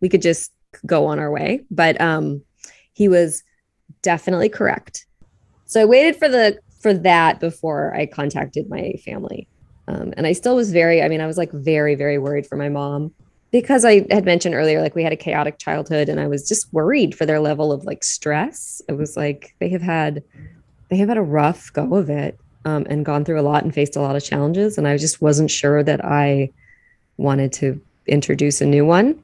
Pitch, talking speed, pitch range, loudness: 155 Hz, 210 wpm, 145-175 Hz, -18 LUFS